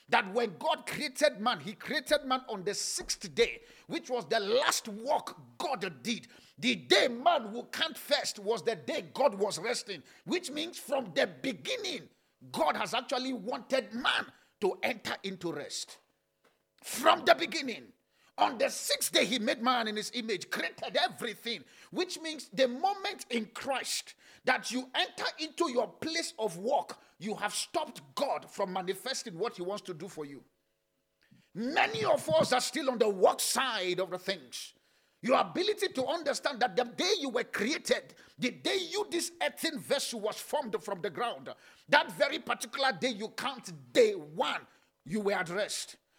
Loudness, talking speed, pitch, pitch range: -32 LUFS, 170 wpm, 250 Hz, 210-310 Hz